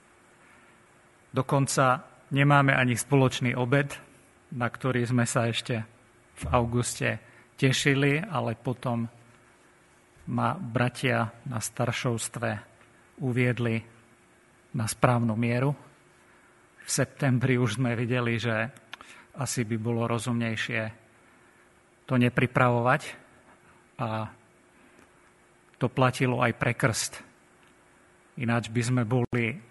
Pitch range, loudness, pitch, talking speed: 115-130 Hz, -27 LUFS, 120 Hz, 90 wpm